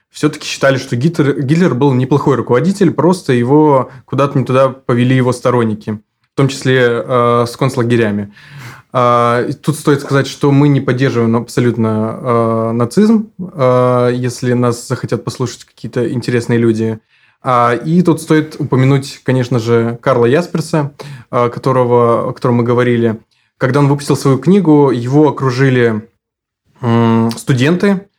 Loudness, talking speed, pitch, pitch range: -13 LUFS, 140 wpm, 130 Hz, 120-145 Hz